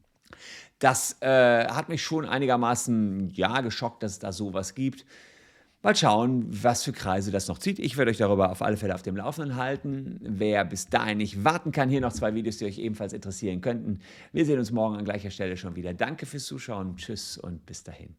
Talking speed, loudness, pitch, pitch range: 210 wpm, -27 LUFS, 110 Hz, 100-130 Hz